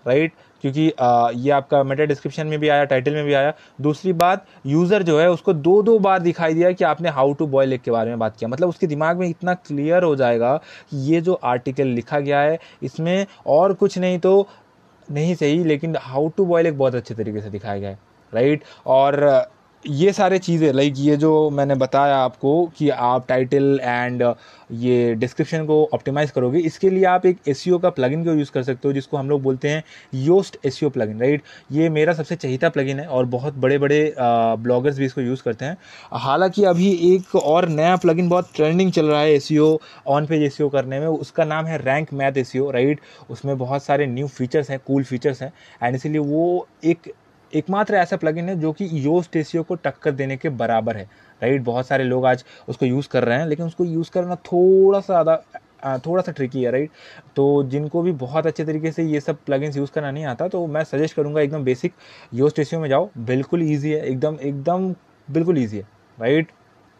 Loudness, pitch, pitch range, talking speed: -20 LUFS, 150 Hz, 135-170 Hz, 210 wpm